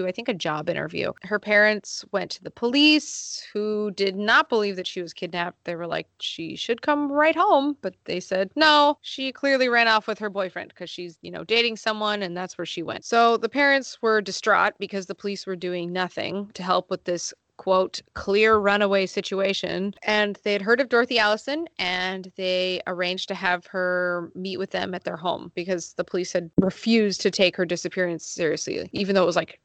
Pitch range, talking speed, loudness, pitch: 180-220 Hz, 205 wpm, -23 LUFS, 195 Hz